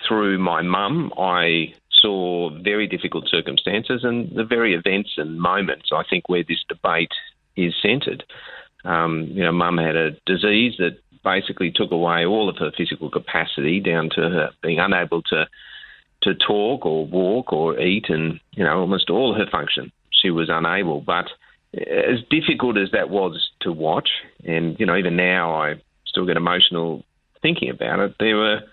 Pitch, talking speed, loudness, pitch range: 90 Hz, 170 wpm, -20 LUFS, 85-105 Hz